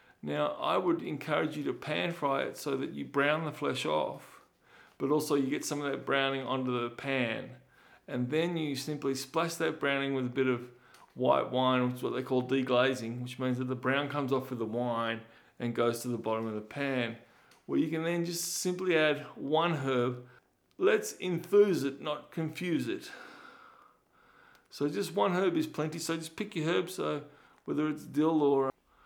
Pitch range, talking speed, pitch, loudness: 125-160 Hz, 200 wpm, 140 Hz, -32 LUFS